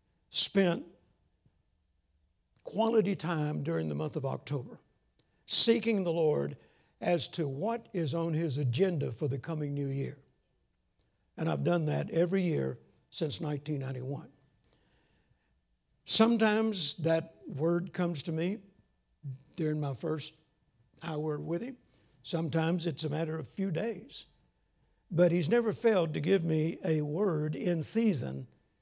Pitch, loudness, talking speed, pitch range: 160 Hz, -31 LUFS, 130 wpm, 145-180 Hz